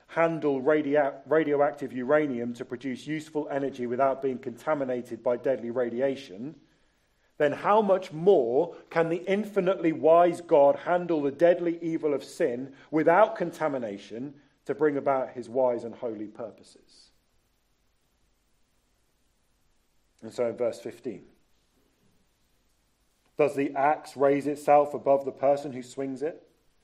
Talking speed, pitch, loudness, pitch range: 125 wpm, 140 Hz, -26 LUFS, 125-155 Hz